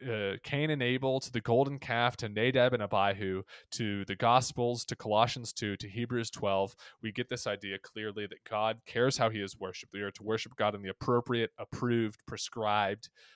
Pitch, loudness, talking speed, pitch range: 115 Hz, -32 LUFS, 195 wpm, 105-125 Hz